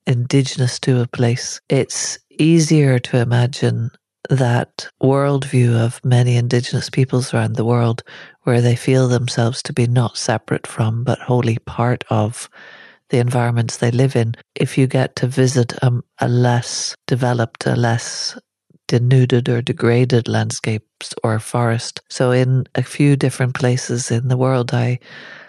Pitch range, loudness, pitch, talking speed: 120-130 Hz, -18 LUFS, 125 Hz, 145 wpm